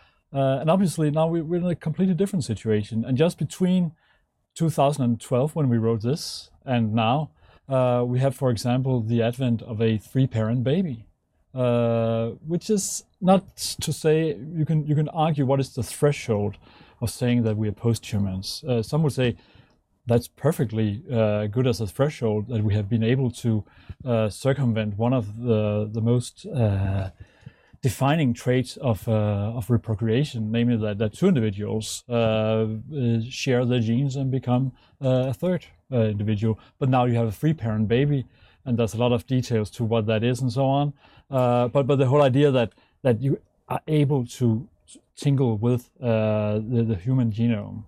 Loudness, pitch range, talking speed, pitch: -24 LUFS, 110-140 Hz, 175 wpm, 120 Hz